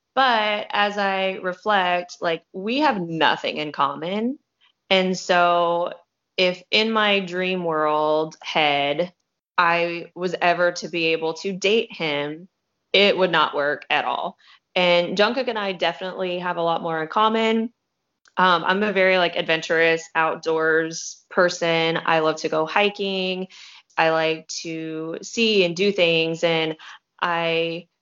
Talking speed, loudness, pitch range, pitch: 140 wpm, -21 LUFS, 160-190 Hz, 175 Hz